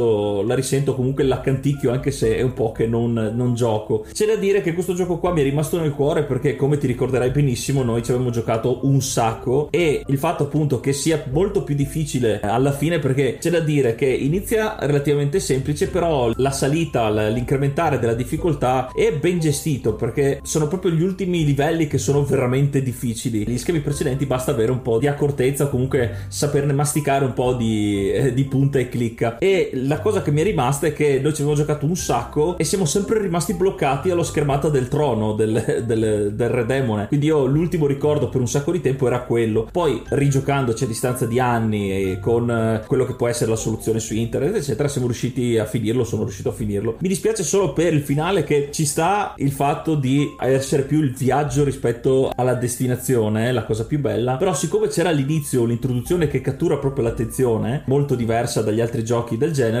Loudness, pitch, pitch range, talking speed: -20 LUFS, 135 Hz, 120-150 Hz, 200 wpm